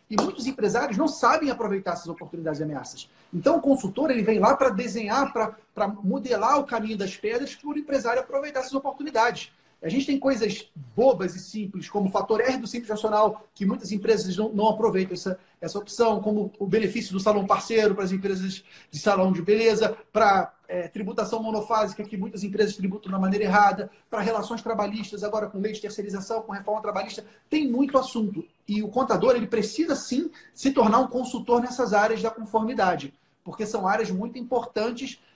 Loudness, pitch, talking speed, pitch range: -25 LUFS, 215 Hz, 185 wpm, 200-240 Hz